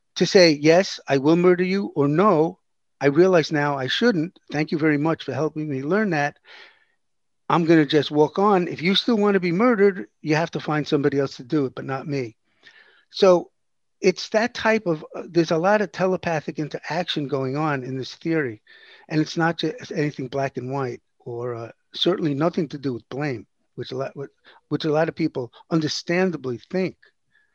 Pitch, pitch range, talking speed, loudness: 160 Hz, 145-185 Hz, 200 wpm, -22 LUFS